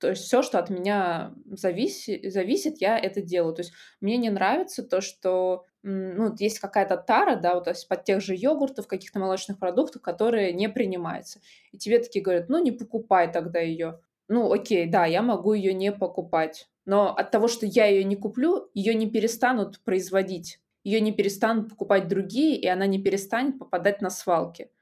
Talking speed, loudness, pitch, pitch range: 185 wpm, -25 LUFS, 200 Hz, 185-225 Hz